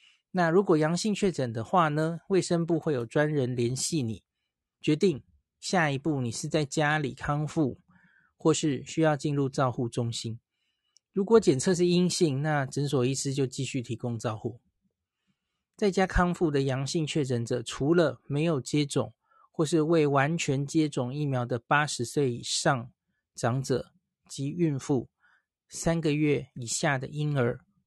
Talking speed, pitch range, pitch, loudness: 225 characters per minute, 130-165 Hz, 150 Hz, -28 LUFS